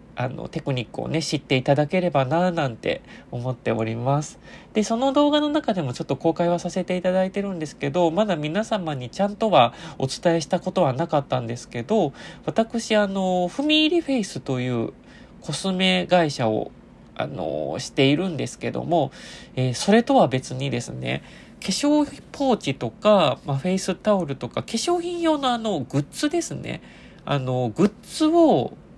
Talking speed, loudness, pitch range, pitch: 355 characters per minute, -23 LUFS, 135-215 Hz, 175 Hz